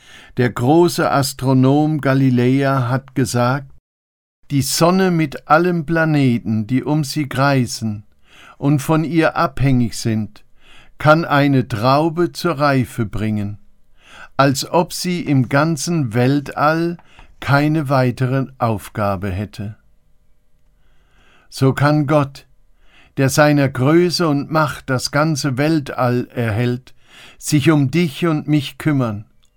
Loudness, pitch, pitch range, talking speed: -17 LUFS, 135 Hz, 120-150 Hz, 110 wpm